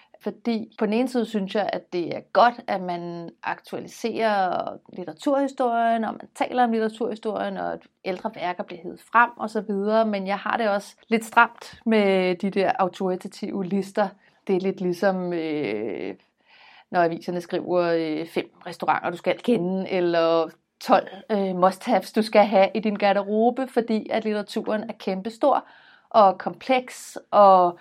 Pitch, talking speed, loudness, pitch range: 200 Hz, 160 wpm, -24 LUFS, 185-225 Hz